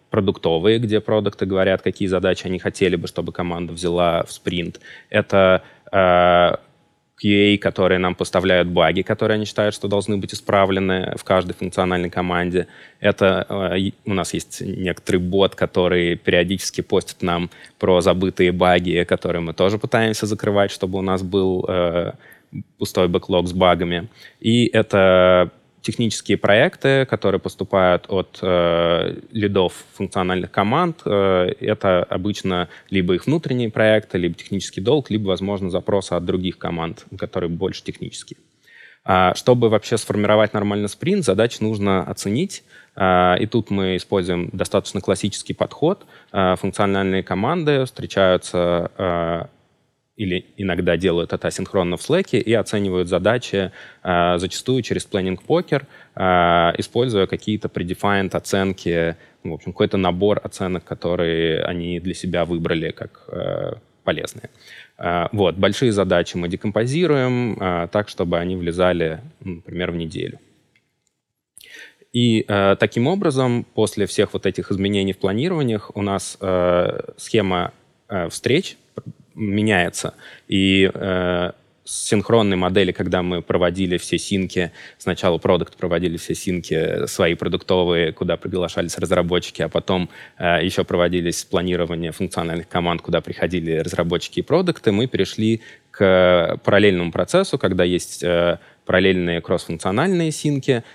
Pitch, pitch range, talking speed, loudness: 95 Hz, 90-105 Hz, 130 wpm, -20 LUFS